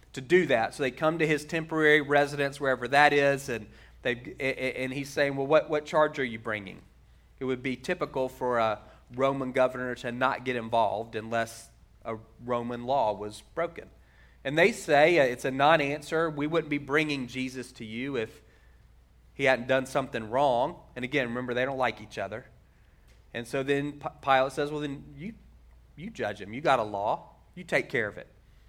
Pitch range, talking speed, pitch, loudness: 120-145 Hz, 190 wpm, 130 Hz, -28 LUFS